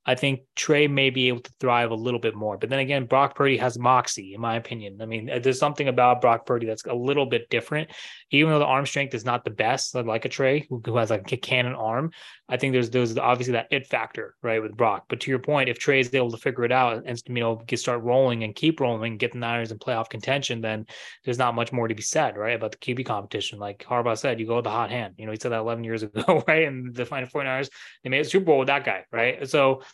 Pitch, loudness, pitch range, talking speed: 125 Hz, -24 LUFS, 115-135 Hz, 275 wpm